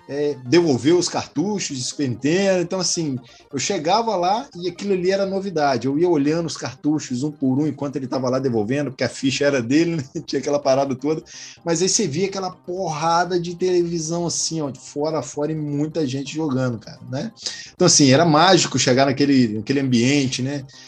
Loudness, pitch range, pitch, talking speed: -20 LUFS, 135-170 Hz, 145 Hz, 195 wpm